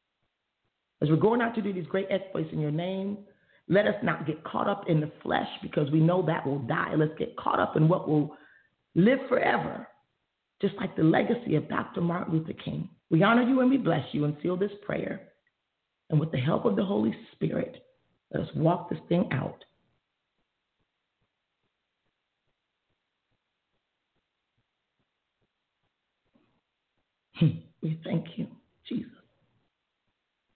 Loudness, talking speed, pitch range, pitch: -28 LUFS, 145 wpm, 155-200 Hz, 175 Hz